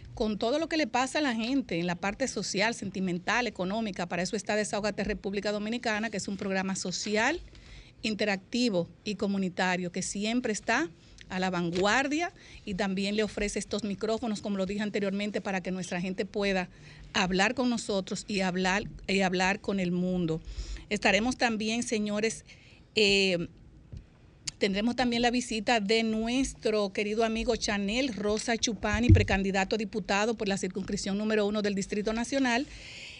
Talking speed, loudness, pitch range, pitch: 155 wpm, -29 LUFS, 195-230 Hz, 210 Hz